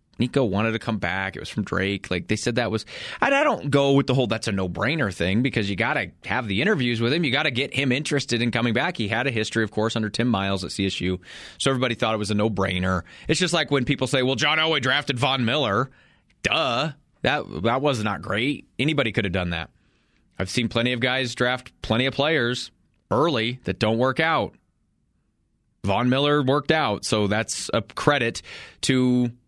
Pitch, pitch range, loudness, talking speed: 120 Hz, 105-135 Hz, -23 LUFS, 220 wpm